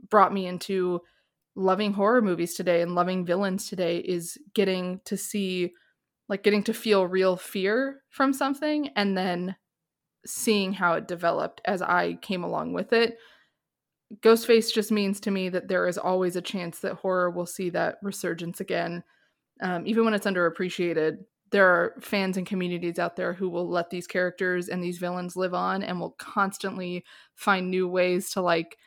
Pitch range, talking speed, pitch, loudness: 180-205 Hz, 175 wpm, 185 Hz, -26 LUFS